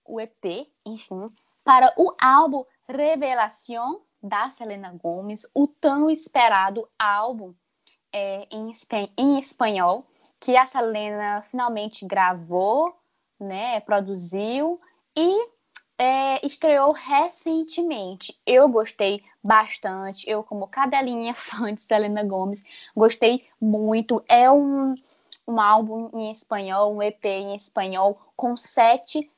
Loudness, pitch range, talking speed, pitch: -22 LUFS, 205-275 Hz, 110 wpm, 225 Hz